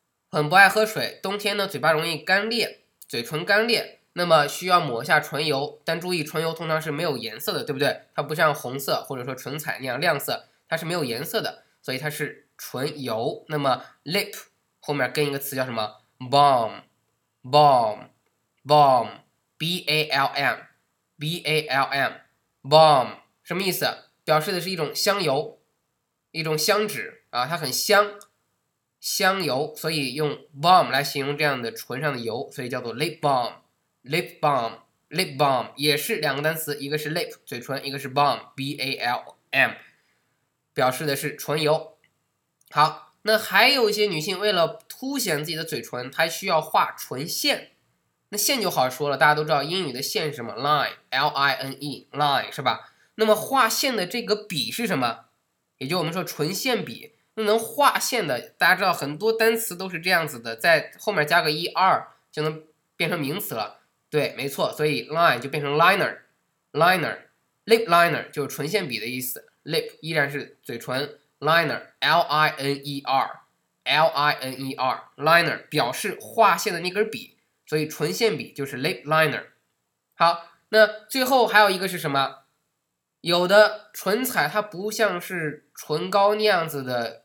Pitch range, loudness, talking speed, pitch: 140-190 Hz, -23 LUFS, 300 characters per minute, 155 Hz